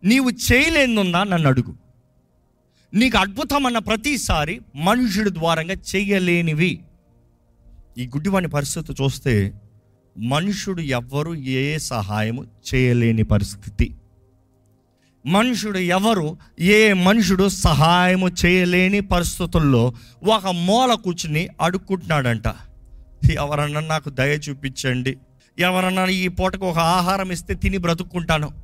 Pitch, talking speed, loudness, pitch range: 165 Hz, 90 wpm, -19 LUFS, 130-190 Hz